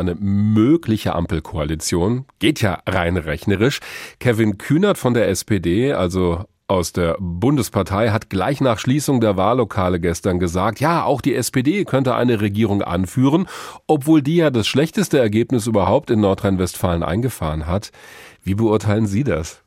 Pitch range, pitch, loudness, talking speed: 90-125 Hz, 110 Hz, -18 LUFS, 145 wpm